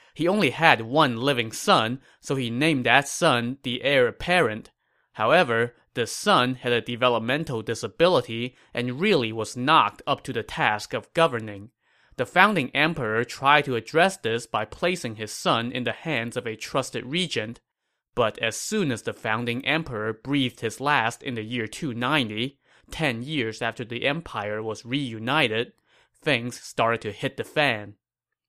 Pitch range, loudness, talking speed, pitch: 115-140 Hz, -24 LUFS, 160 wpm, 125 Hz